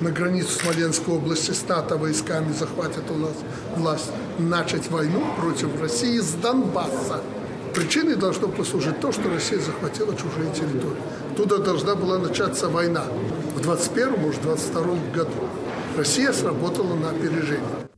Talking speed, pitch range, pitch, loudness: 125 wpm, 155-185 Hz, 165 Hz, -24 LUFS